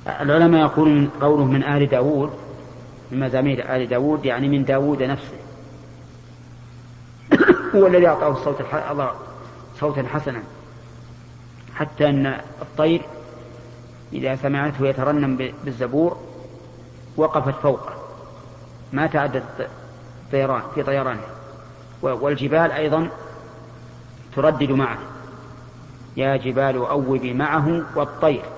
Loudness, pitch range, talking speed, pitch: -20 LUFS, 125-150 Hz, 90 wpm, 135 Hz